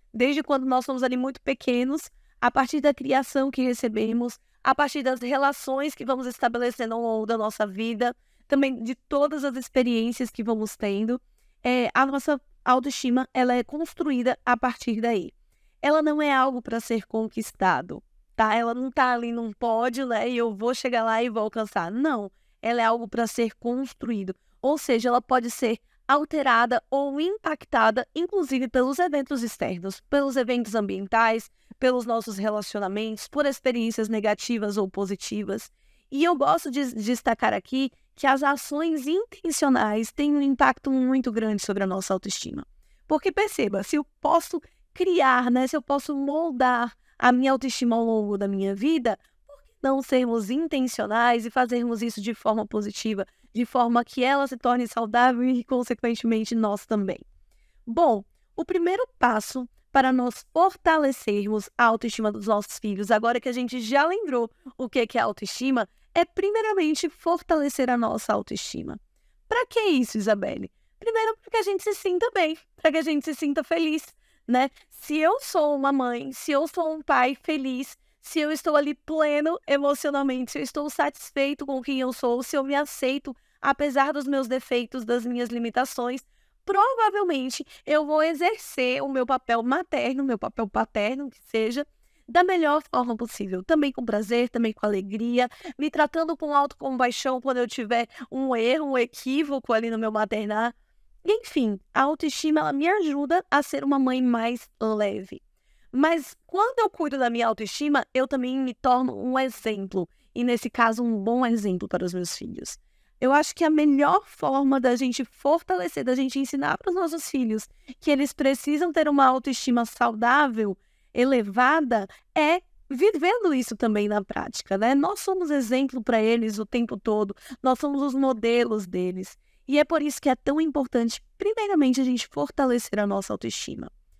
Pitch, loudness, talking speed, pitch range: 255 Hz, -25 LUFS, 165 wpm, 230-290 Hz